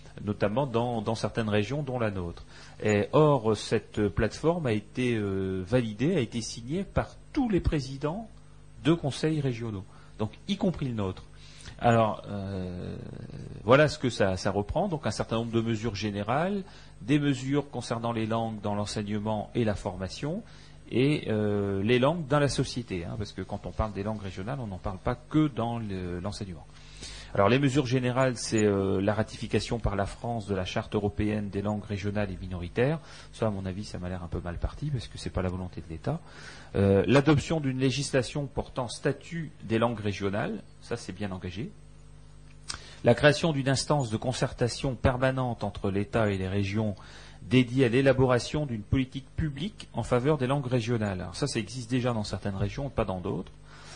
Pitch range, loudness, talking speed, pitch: 100-135 Hz, -29 LUFS, 185 wpm, 115 Hz